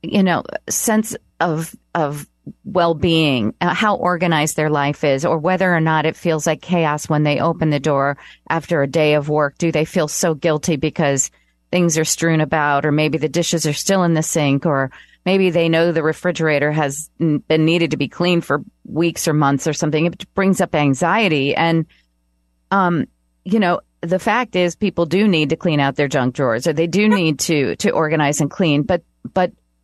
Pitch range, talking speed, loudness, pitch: 150-175 Hz, 195 wpm, -18 LUFS, 160 Hz